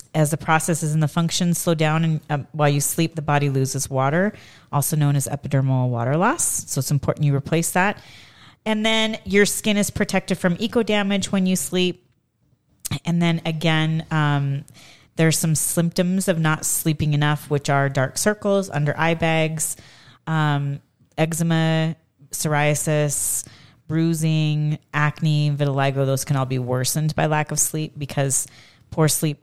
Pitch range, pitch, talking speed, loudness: 140-165 Hz, 155 Hz, 155 wpm, -21 LUFS